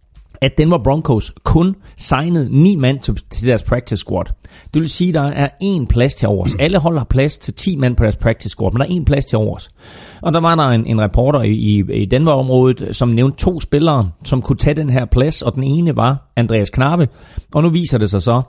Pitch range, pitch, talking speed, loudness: 110-150 Hz, 130 Hz, 230 wpm, -15 LUFS